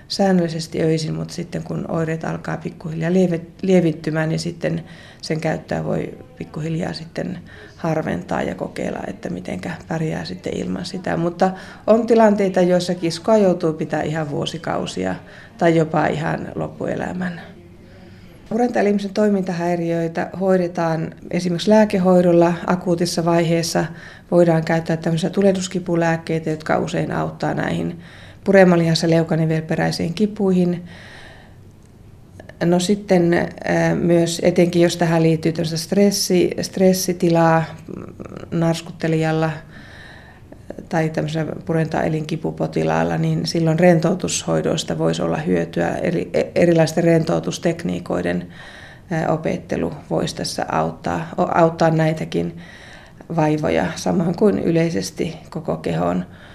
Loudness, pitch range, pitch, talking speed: -19 LUFS, 155-180 Hz, 165 Hz, 100 wpm